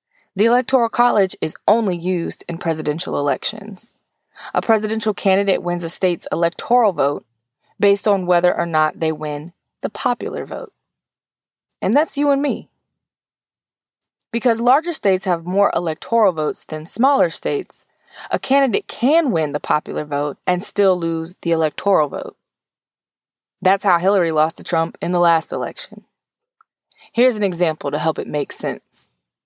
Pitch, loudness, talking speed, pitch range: 185 Hz, -19 LUFS, 150 wpm, 165-225 Hz